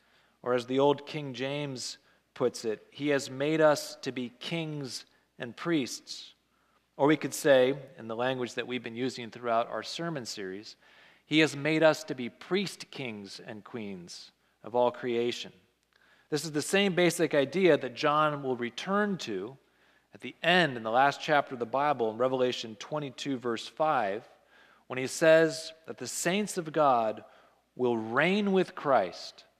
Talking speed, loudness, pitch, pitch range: 170 wpm, -29 LUFS, 140 Hz, 125-155 Hz